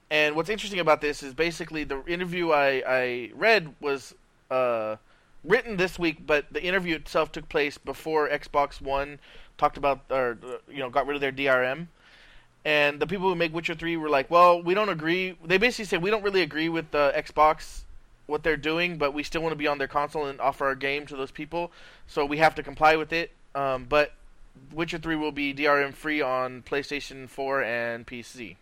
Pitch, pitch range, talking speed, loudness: 150 Hz, 135-165 Hz, 205 wpm, -26 LUFS